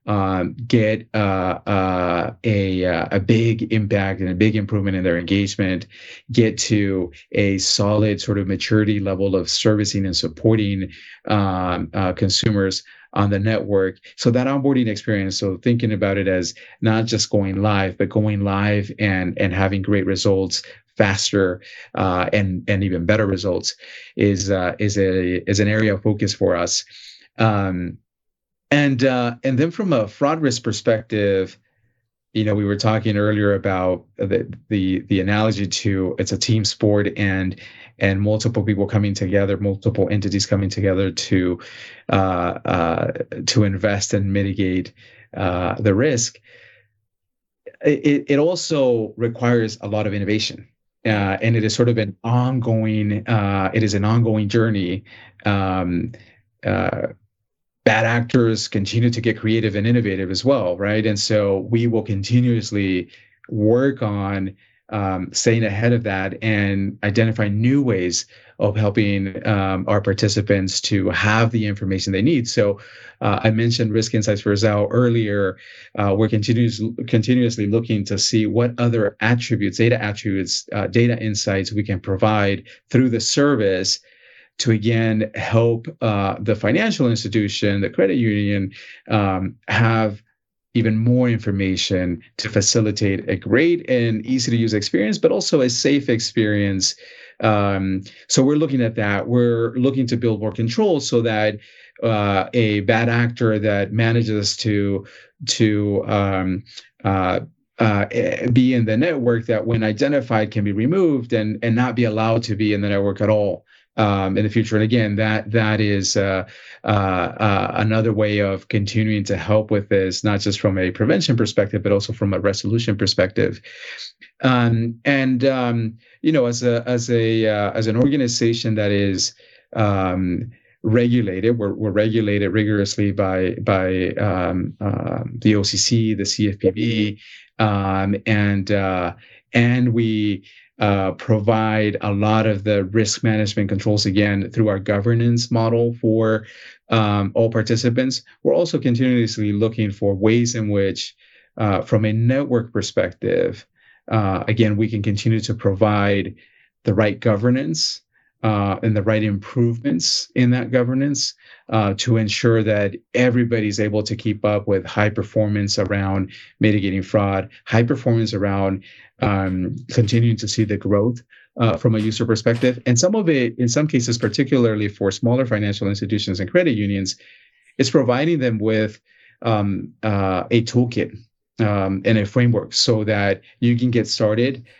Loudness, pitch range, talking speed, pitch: -19 LUFS, 100-115 Hz, 150 wpm, 105 Hz